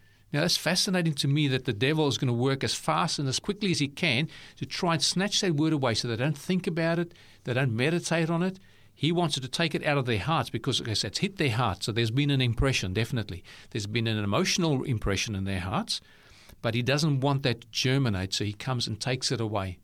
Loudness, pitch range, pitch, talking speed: -27 LUFS, 115-160 Hz, 135 Hz, 250 wpm